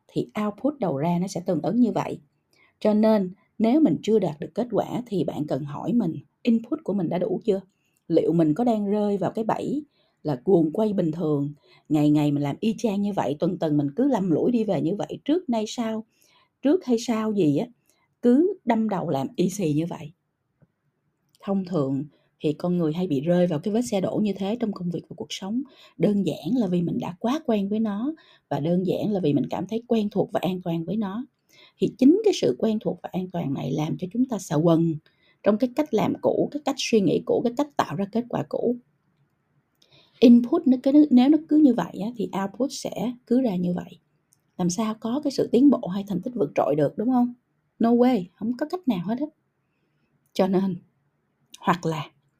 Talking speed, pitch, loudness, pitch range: 225 wpm, 200 Hz, -24 LUFS, 165-240 Hz